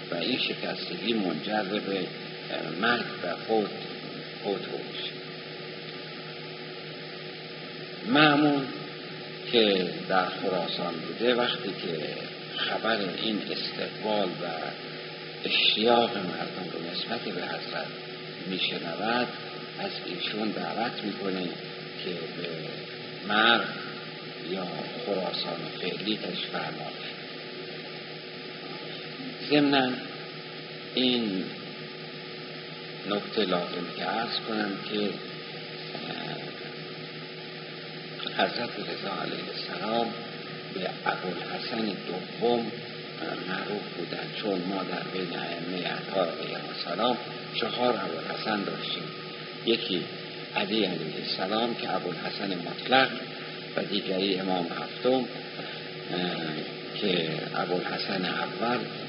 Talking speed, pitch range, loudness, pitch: 85 wpm, 95-120 Hz, -30 LUFS, 110 Hz